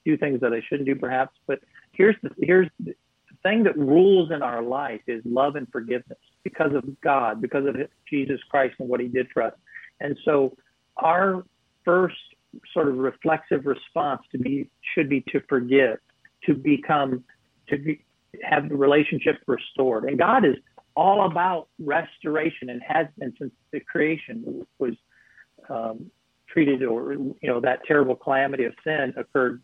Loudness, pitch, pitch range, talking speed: -24 LUFS, 140 Hz, 130-155 Hz, 165 wpm